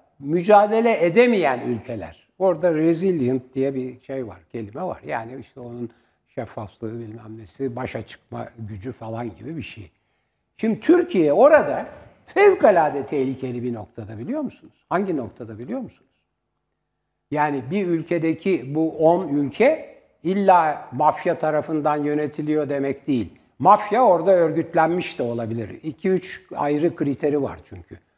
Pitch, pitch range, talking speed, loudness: 145 Hz, 120-170 Hz, 125 wpm, -21 LUFS